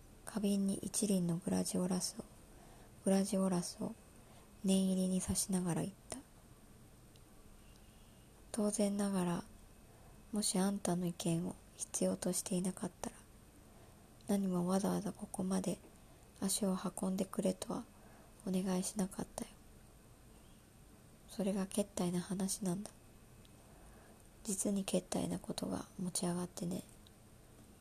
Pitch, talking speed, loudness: 185 Hz, 235 characters per minute, -38 LUFS